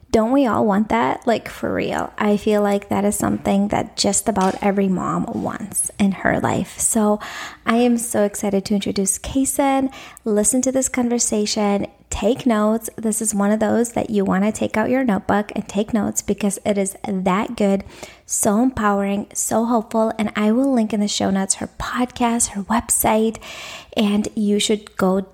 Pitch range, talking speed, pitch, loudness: 200-230 Hz, 185 wpm, 215 Hz, -19 LUFS